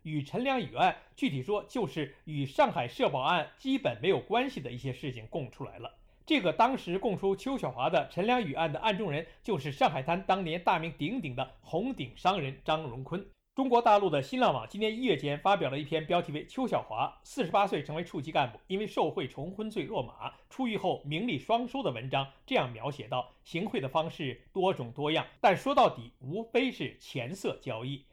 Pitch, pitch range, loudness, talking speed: 165 Hz, 140-215 Hz, -31 LUFS, 310 characters per minute